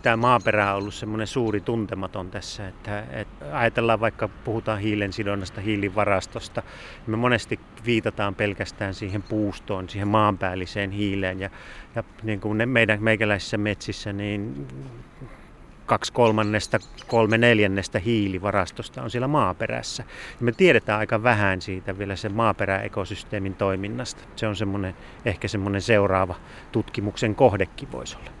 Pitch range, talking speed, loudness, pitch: 100-110 Hz, 130 wpm, -24 LUFS, 105 Hz